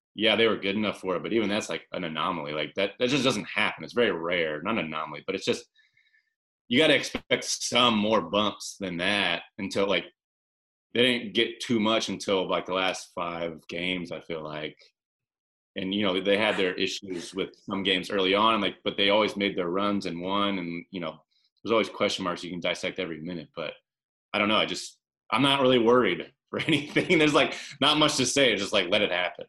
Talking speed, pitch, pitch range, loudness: 225 wpm, 100 Hz, 85-115 Hz, -26 LUFS